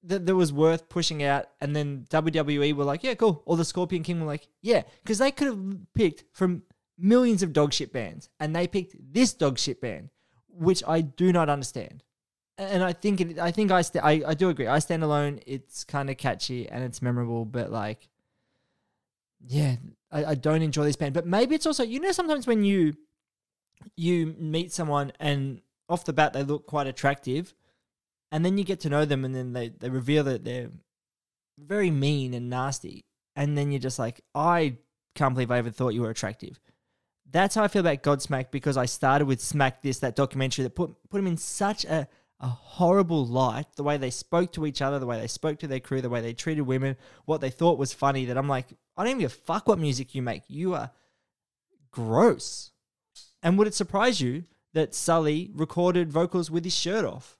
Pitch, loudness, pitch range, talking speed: 150 Hz, -27 LUFS, 135-175 Hz, 210 wpm